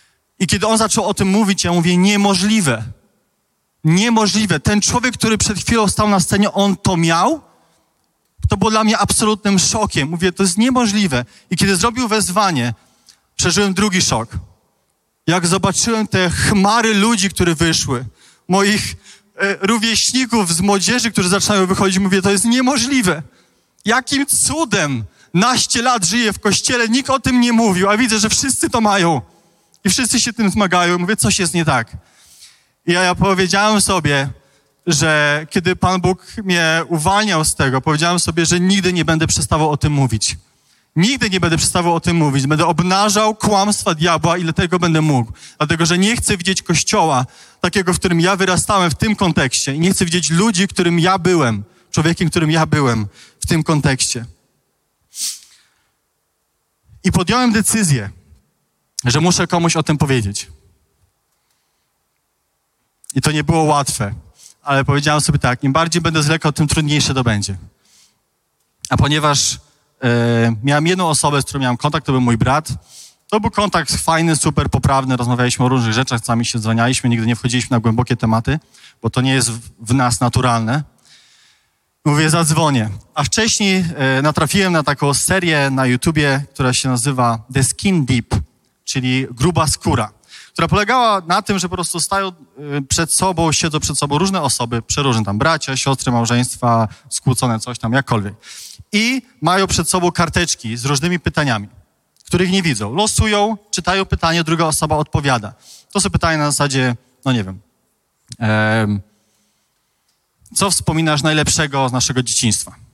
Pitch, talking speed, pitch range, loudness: 165 Hz, 155 wpm, 130-195 Hz, -15 LUFS